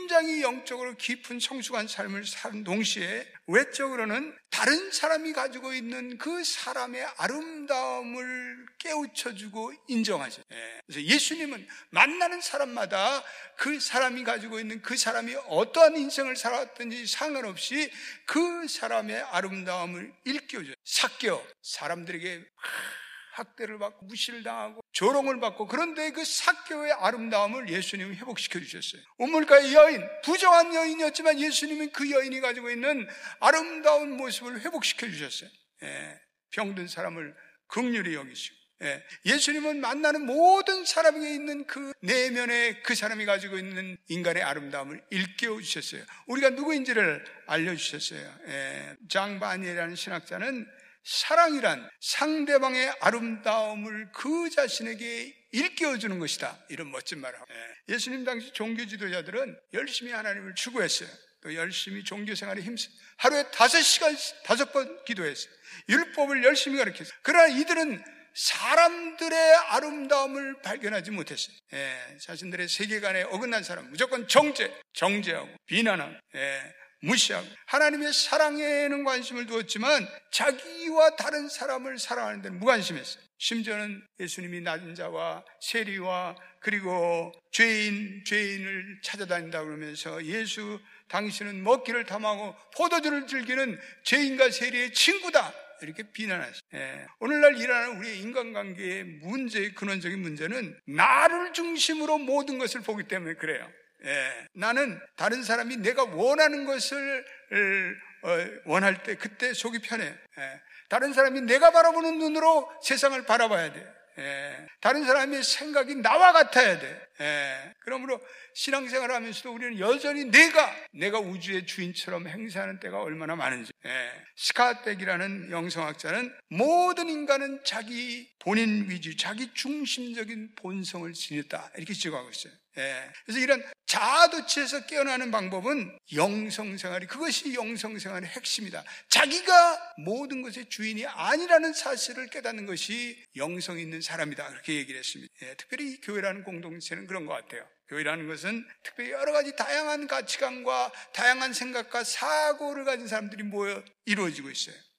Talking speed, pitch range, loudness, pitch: 335 characters per minute, 200-290 Hz, -27 LUFS, 245 Hz